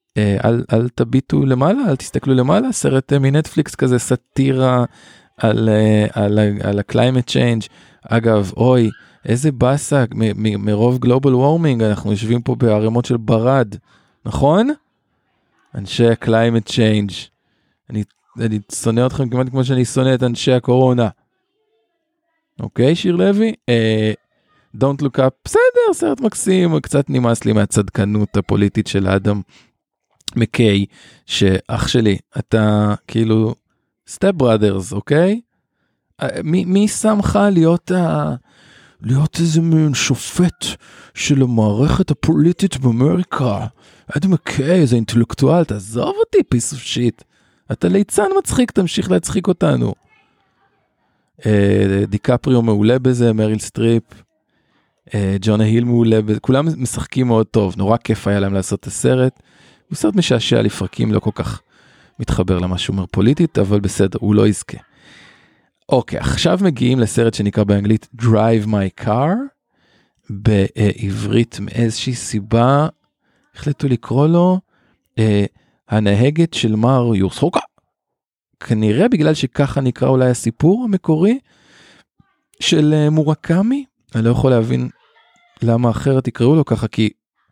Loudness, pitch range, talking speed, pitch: -16 LUFS, 110-150 Hz, 115 wpm, 120 Hz